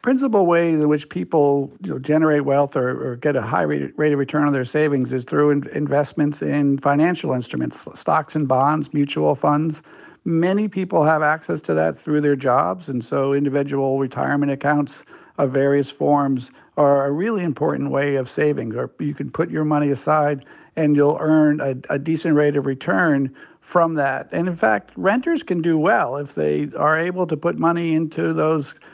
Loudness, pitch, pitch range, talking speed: -20 LUFS, 145 Hz, 140-155 Hz, 185 wpm